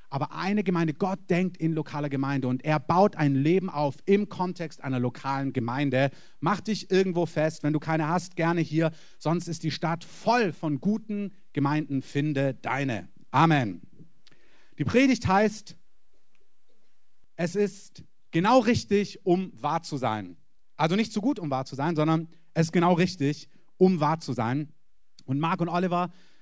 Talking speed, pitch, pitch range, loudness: 165 wpm, 165 Hz, 145-185 Hz, -27 LUFS